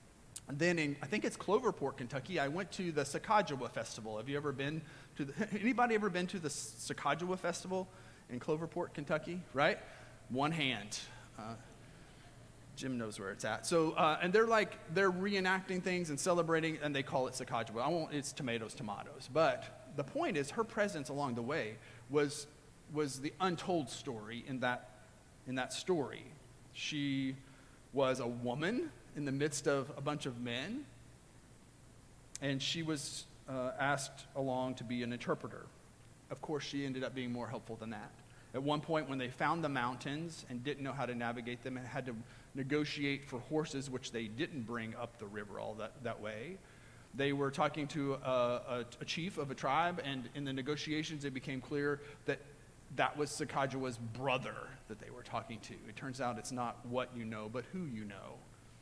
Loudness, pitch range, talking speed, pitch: -38 LUFS, 125-155 Hz, 185 wpm, 135 Hz